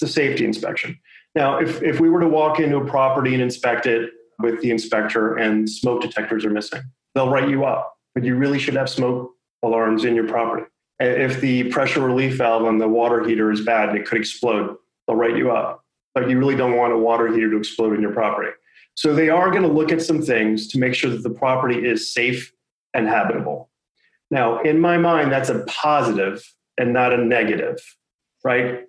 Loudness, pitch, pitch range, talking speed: -20 LUFS, 125 Hz, 115-135 Hz, 210 wpm